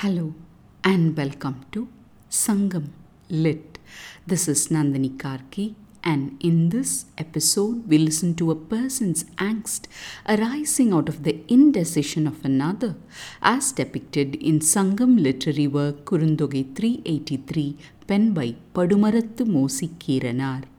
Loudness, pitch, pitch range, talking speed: -22 LUFS, 160 Hz, 145-210 Hz, 125 wpm